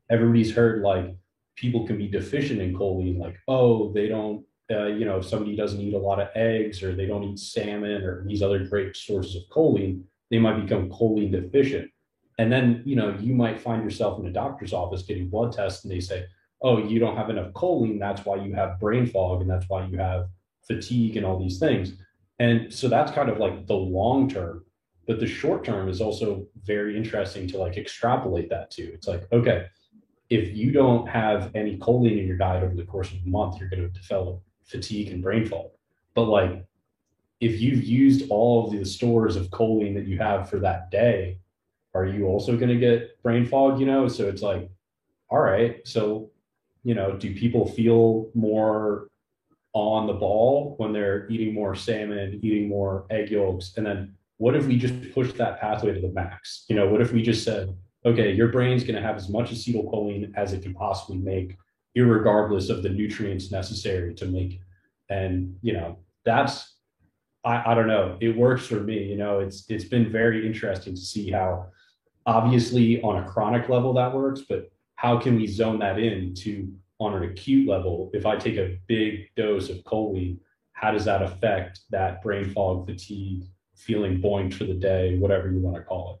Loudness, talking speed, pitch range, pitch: -25 LUFS, 200 wpm, 95-115 Hz, 105 Hz